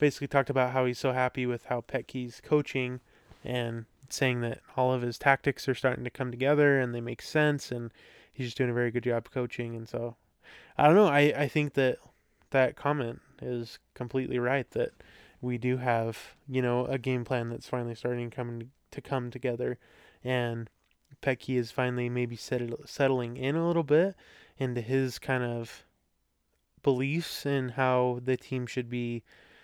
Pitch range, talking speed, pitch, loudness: 120-135 Hz, 175 wpm, 125 Hz, -30 LUFS